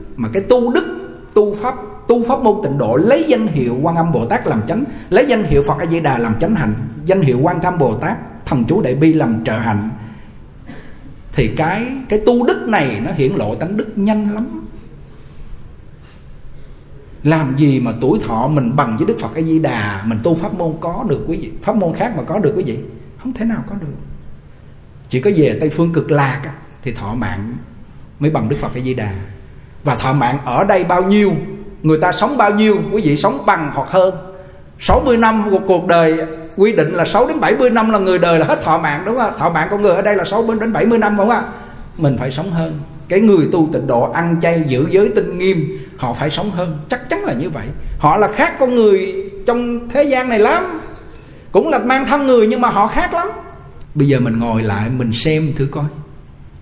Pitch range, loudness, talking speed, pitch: 135-210 Hz, -15 LUFS, 225 wpm, 165 Hz